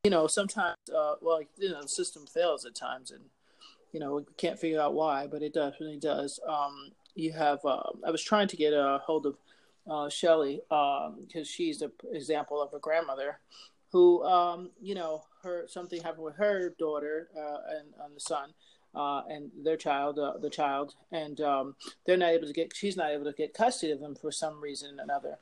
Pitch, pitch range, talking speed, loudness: 155 Hz, 145-175 Hz, 210 wpm, -31 LUFS